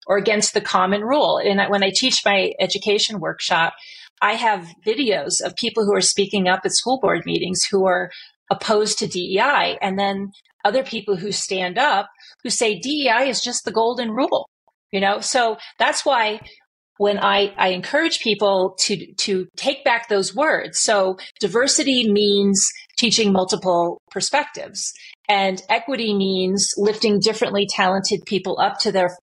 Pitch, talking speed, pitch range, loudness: 205 Hz, 160 wpm, 195-230 Hz, -19 LUFS